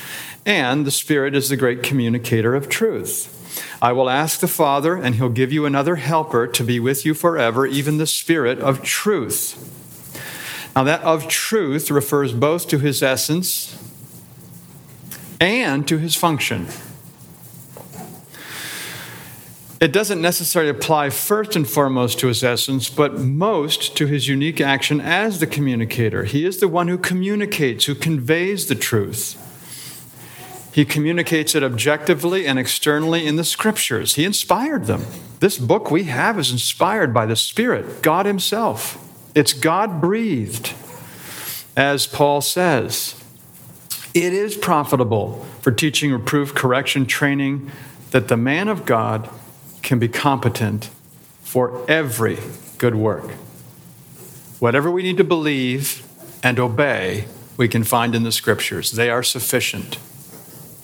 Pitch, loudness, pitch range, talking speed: 140 Hz, -19 LUFS, 125-160 Hz, 135 wpm